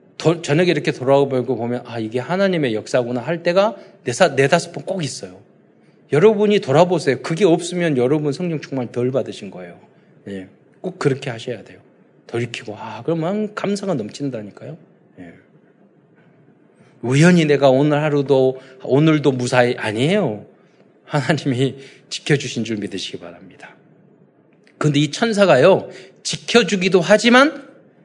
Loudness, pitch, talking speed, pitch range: -18 LUFS, 145 Hz, 310 characters per minute, 125-180 Hz